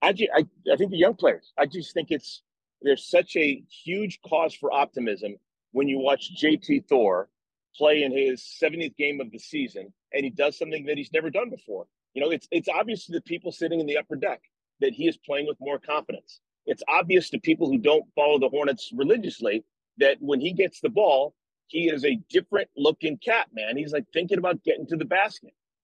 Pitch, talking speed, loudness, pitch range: 160 Hz, 215 wpm, -25 LUFS, 145-210 Hz